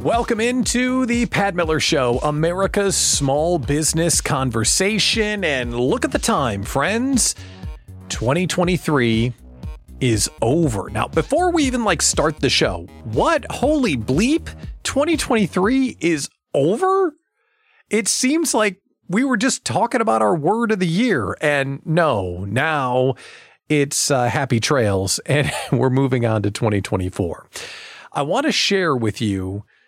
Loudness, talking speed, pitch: -19 LUFS, 130 wpm, 160 Hz